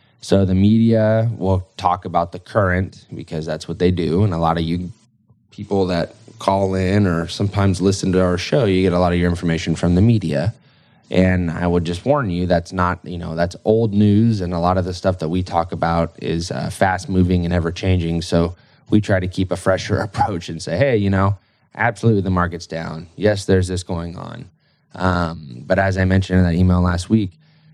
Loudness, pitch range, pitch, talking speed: -19 LUFS, 85-100 Hz, 90 Hz, 215 wpm